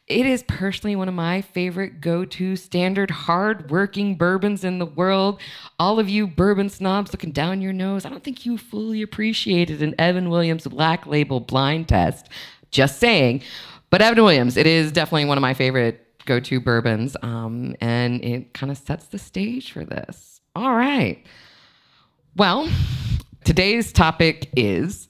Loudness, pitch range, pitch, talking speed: -20 LUFS, 140-200 Hz, 175 Hz, 165 wpm